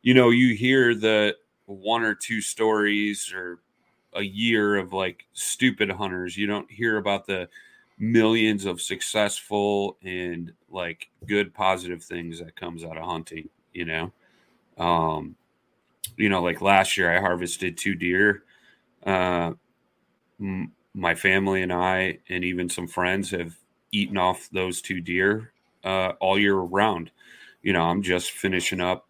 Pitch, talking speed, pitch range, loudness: 95 Hz, 150 wpm, 90-105 Hz, -24 LUFS